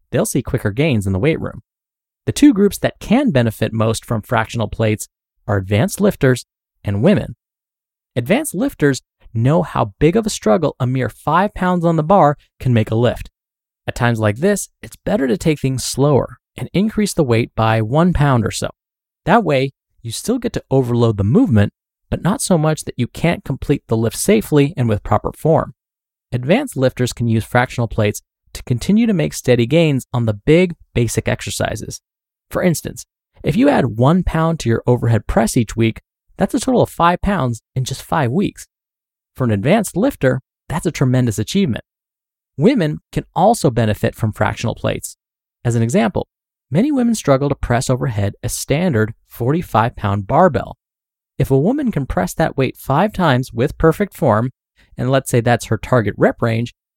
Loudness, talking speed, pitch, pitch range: -17 LUFS, 185 wpm, 125 Hz, 115-160 Hz